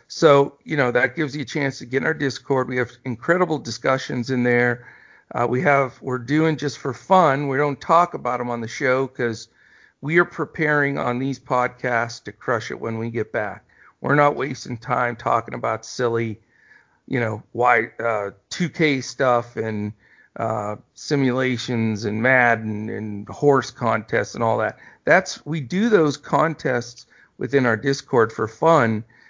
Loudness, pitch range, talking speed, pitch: -21 LUFS, 115-145 Hz, 170 wpm, 125 Hz